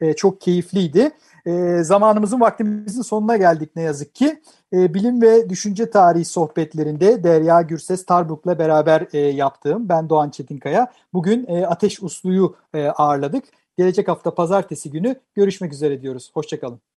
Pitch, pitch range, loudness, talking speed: 175 Hz, 155-205 Hz, -18 LUFS, 120 wpm